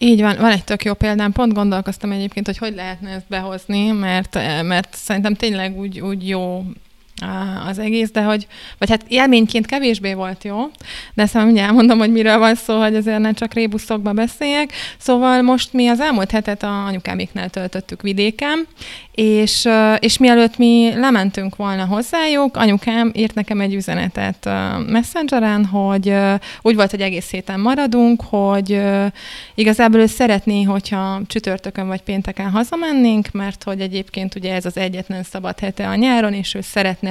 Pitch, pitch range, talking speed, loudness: 210 Hz, 195-230 Hz, 160 wpm, -17 LUFS